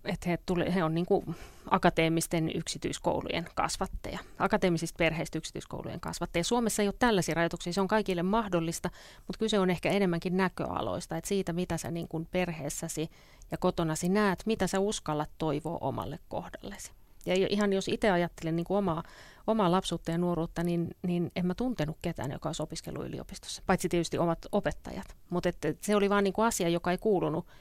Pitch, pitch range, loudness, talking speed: 175 Hz, 165-195 Hz, -31 LUFS, 175 wpm